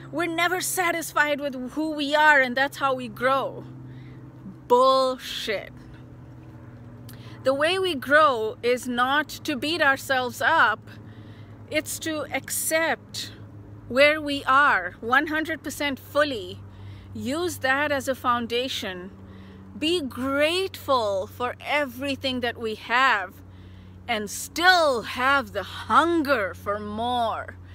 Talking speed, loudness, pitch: 110 wpm, -23 LUFS, 265 Hz